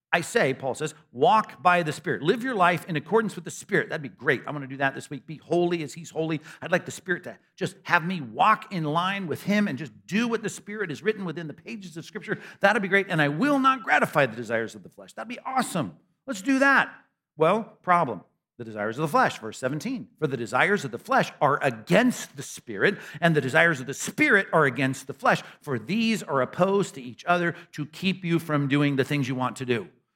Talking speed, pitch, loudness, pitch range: 245 wpm, 170 Hz, -25 LUFS, 140-200 Hz